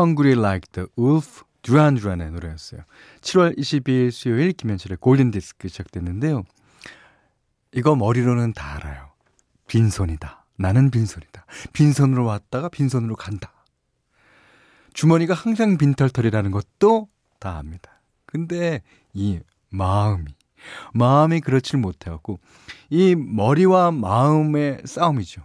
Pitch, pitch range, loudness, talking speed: 120 Hz, 95-150 Hz, -20 LUFS, 300 characters per minute